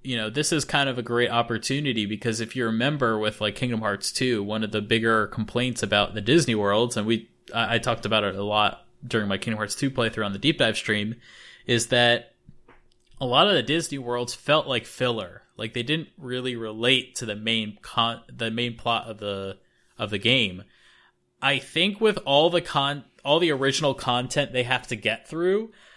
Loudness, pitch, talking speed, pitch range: -24 LUFS, 120 Hz, 205 wpm, 110-135 Hz